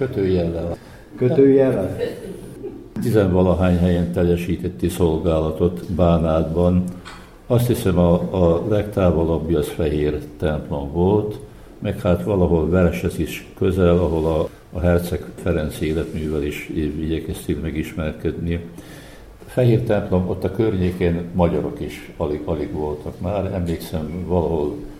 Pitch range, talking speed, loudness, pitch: 80-95 Hz, 110 wpm, -20 LUFS, 90 Hz